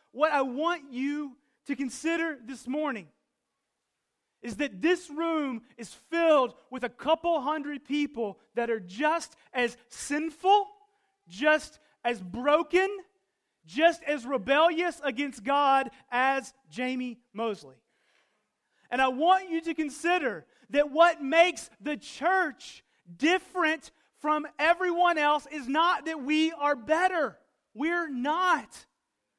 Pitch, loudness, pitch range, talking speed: 295 Hz, -28 LUFS, 260-330 Hz, 120 wpm